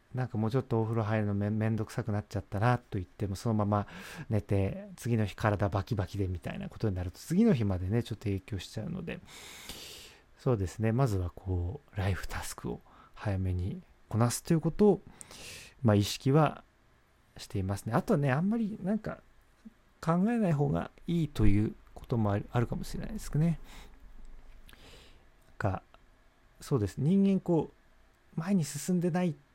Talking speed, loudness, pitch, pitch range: 310 characters per minute, -32 LUFS, 115 Hz, 100-160 Hz